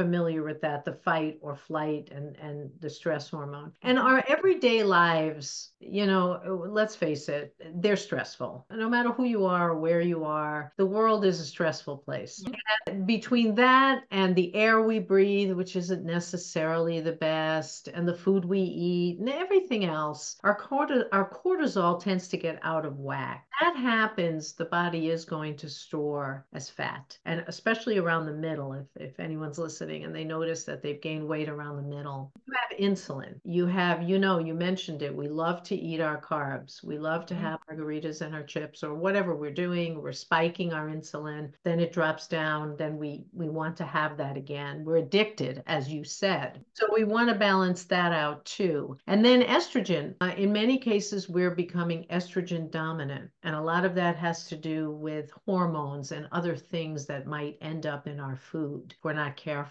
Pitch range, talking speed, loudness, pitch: 150-190 Hz, 190 wpm, -29 LUFS, 165 Hz